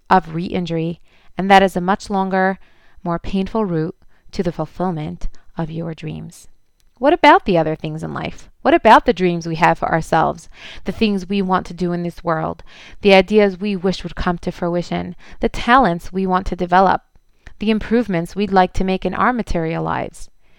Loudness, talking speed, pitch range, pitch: -18 LUFS, 190 wpm, 170-195 Hz, 185 Hz